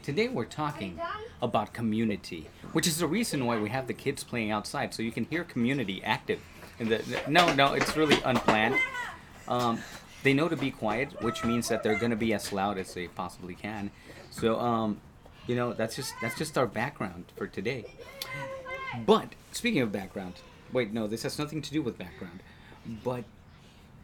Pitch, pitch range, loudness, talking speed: 115 Hz, 105-140 Hz, -30 LUFS, 180 wpm